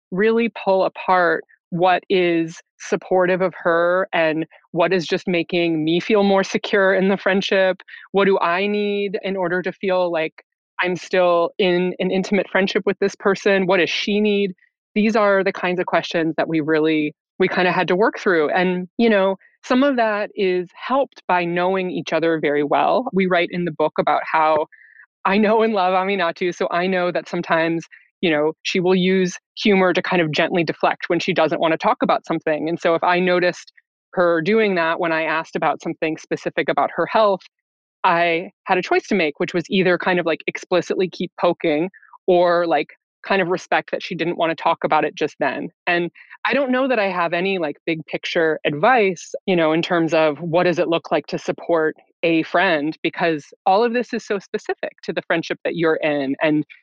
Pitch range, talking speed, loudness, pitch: 170-195 Hz, 205 wpm, -19 LUFS, 180 Hz